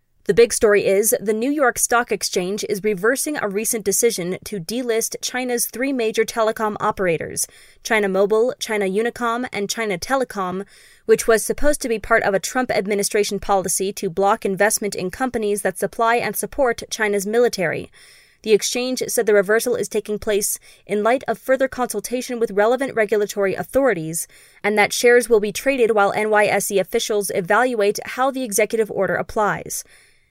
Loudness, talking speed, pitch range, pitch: -20 LUFS, 160 wpm, 205-240 Hz, 220 Hz